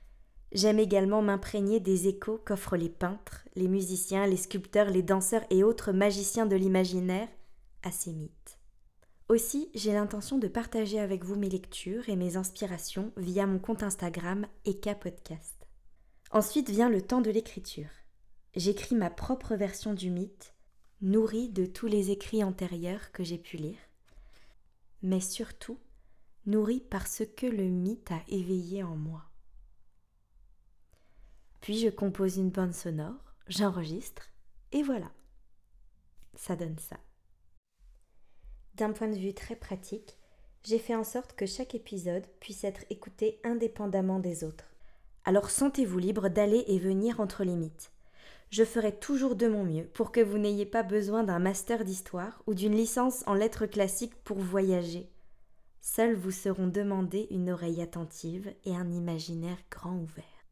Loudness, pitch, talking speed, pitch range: -31 LUFS, 195 Hz, 145 wpm, 175-215 Hz